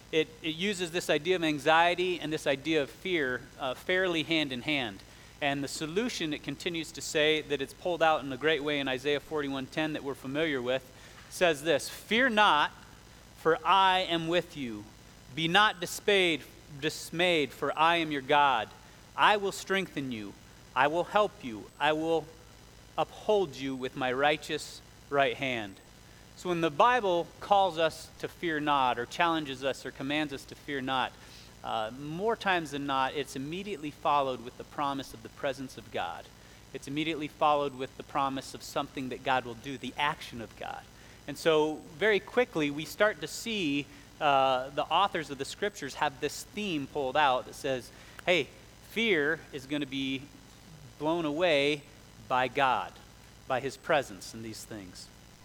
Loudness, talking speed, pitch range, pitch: -30 LUFS, 175 wpm, 130-165 Hz, 145 Hz